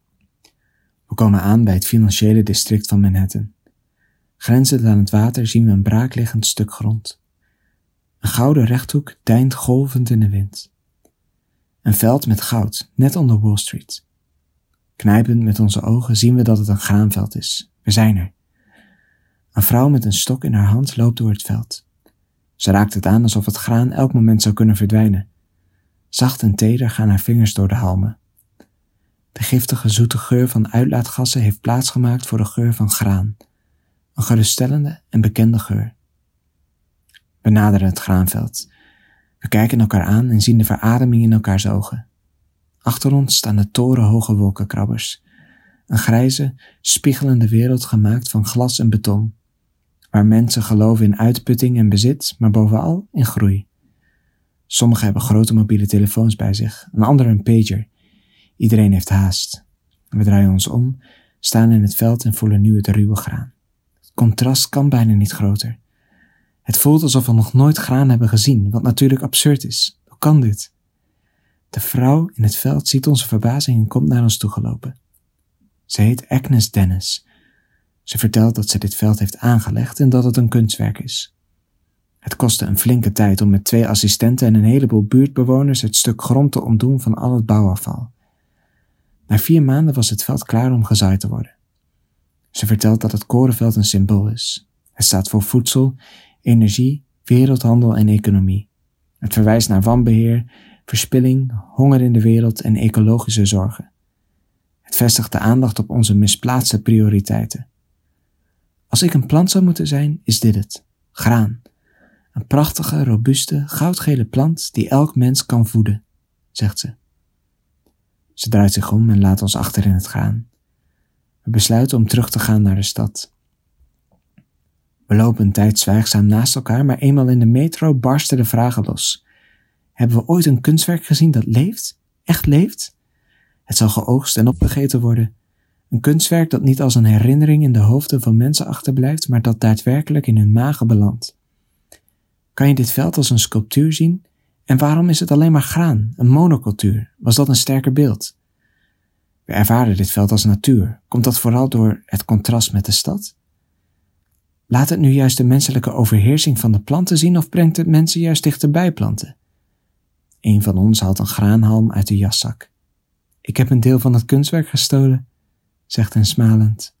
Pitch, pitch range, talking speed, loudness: 110 Hz, 105-125 Hz, 165 wpm, -15 LUFS